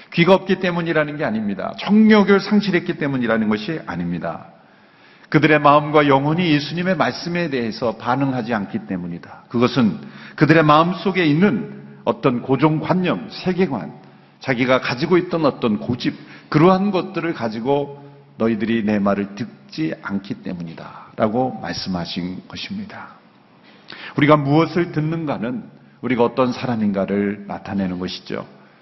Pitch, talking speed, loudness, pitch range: 145 Hz, 325 characters per minute, -19 LUFS, 110-175 Hz